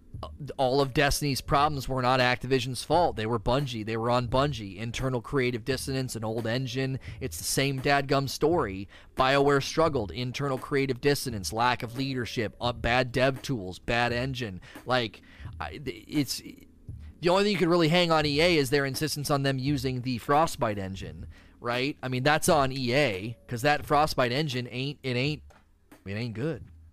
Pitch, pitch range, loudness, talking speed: 130 Hz, 120-140 Hz, -27 LUFS, 175 wpm